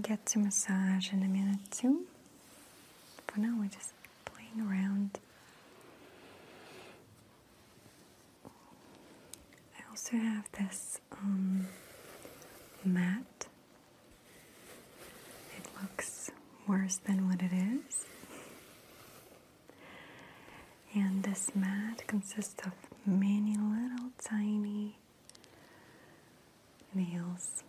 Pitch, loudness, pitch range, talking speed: 200 Hz, -35 LUFS, 190-215 Hz, 75 wpm